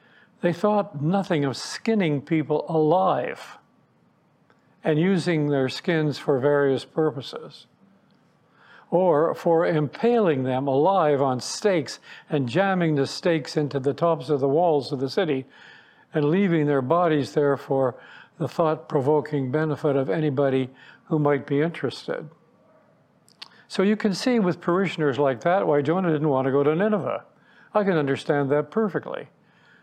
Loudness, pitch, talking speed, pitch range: -23 LUFS, 155 Hz, 145 wpm, 140-175 Hz